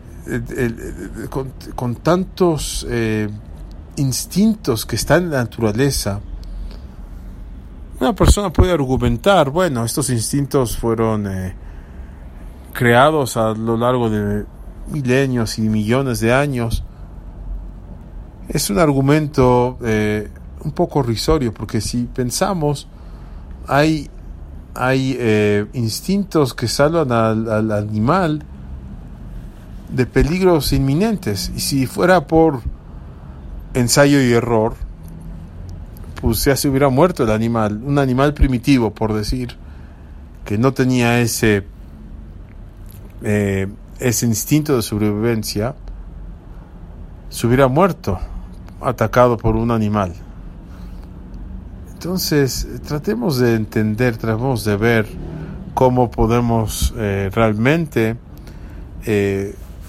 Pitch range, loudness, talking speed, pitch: 90-130 Hz, -17 LUFS, 100 wpm, 110 Hz